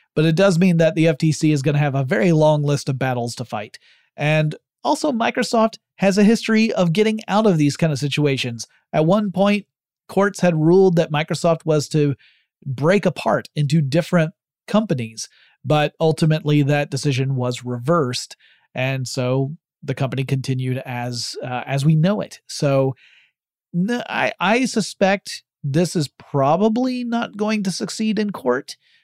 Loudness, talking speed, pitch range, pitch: -19 LUFS, 160 wpm, 140-195 Hz, 160 Hz